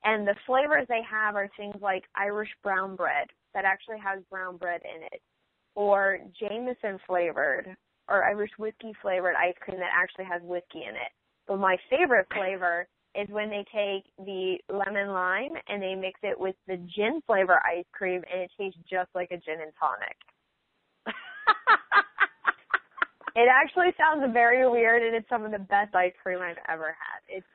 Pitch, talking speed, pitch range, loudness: 195 Hz, 175 wpm, 185-215 Hz, -27 LUFS